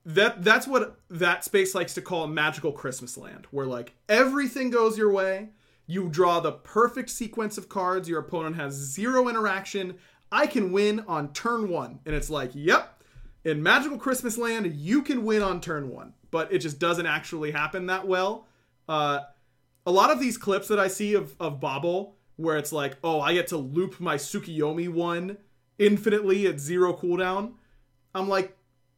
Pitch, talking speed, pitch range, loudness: 185 Hz, 180 wpm, 155-210 Hz, -26 LUFS